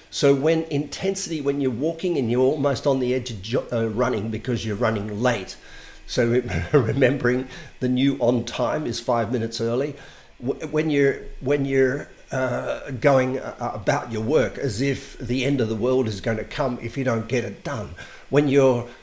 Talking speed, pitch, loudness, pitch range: 175 wpm, 130 Hz, -23 LUFS, 120-140 Hz